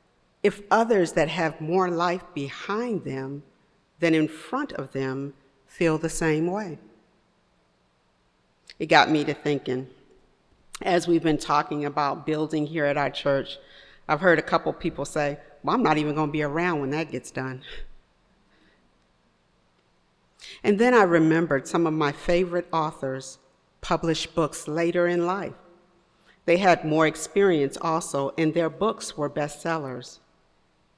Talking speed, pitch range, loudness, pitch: 140 wpm, 140-170 Hz, -25 LUFS, 155 Hz